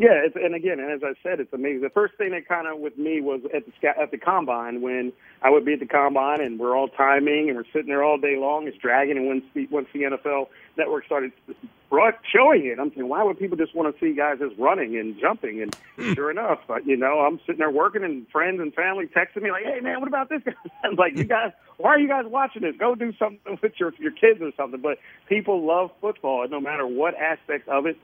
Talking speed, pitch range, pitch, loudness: 255 wpm, 140-205 Hz, 155 Hz, -23 LUFS